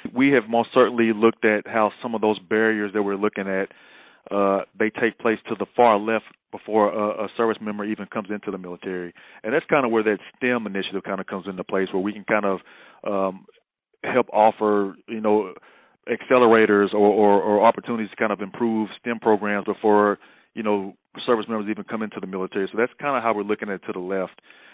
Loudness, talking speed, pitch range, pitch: -22 LUFS, 215 wpm, 100-110 Hz, 105 Hz